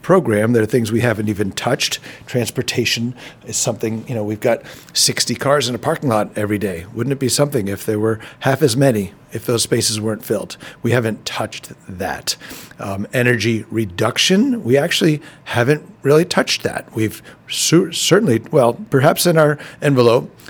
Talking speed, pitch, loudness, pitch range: 175 wpm, 120 Hz, -17 LUFS, 110-145 Hz